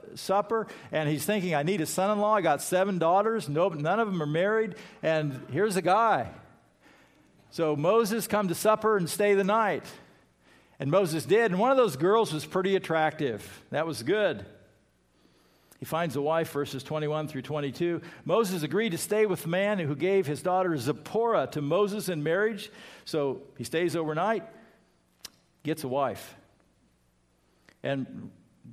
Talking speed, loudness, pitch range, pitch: 165 wpm, -28 LUFS, 150-205 Hz, 170 Hz